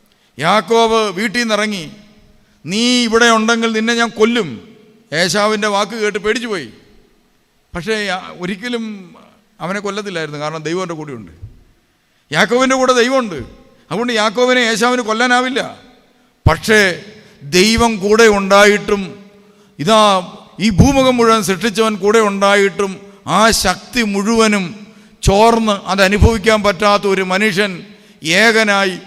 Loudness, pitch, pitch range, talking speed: -13 LUFS, 210 Hz, 195-225 Hz, 100 wpm